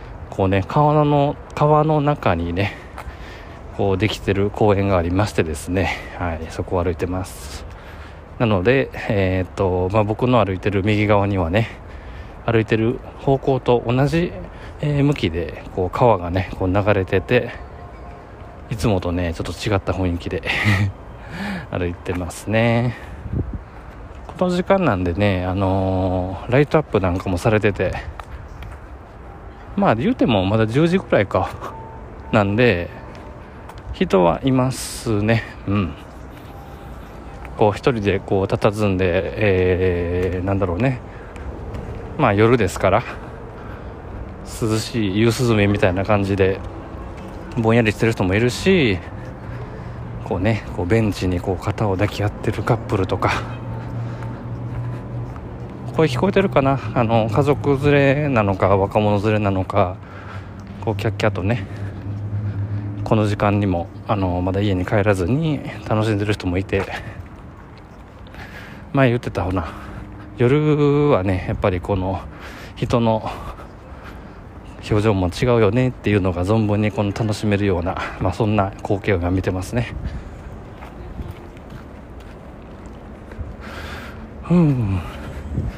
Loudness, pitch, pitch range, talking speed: -20 LUFS, 100 Hz, 95-115 Hz, 240 characters per minute